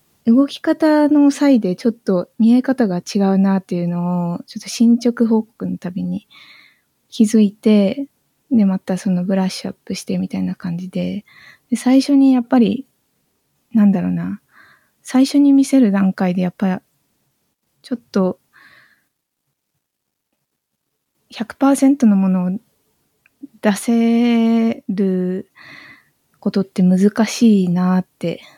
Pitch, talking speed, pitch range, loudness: 210 Hz, 225 characters per minute, 185-245 Hz, -16 LUFS